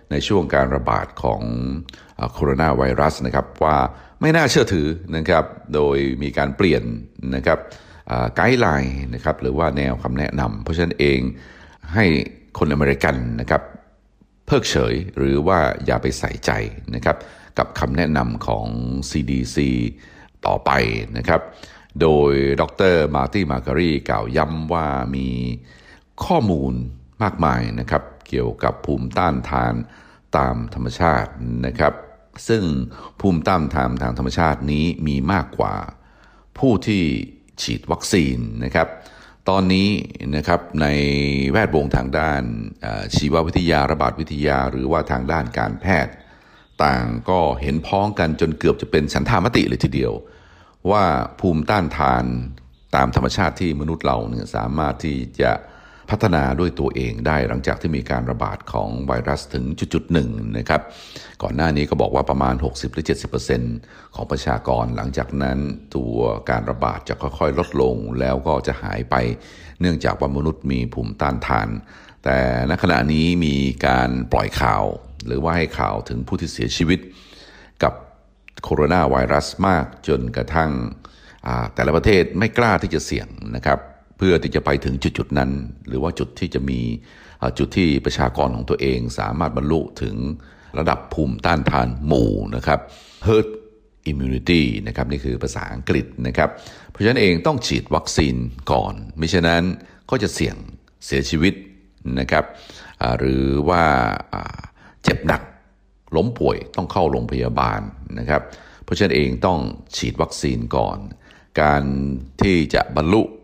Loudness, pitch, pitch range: -20 LUFS, 70 Hz, 65-80 Hz